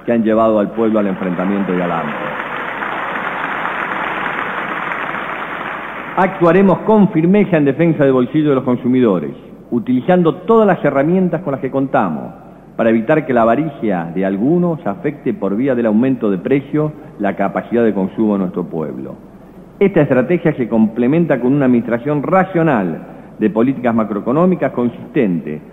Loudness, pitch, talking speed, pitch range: -15 LUFS, 130 Hz, 140 wpm, 110-160 Hz